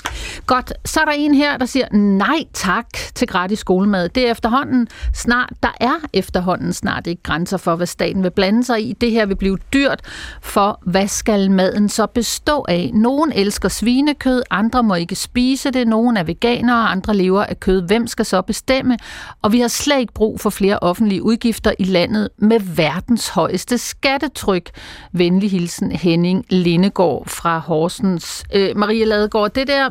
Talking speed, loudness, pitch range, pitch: 185 wpm, -17 LUFS, 190-245 Hz, 215 Hz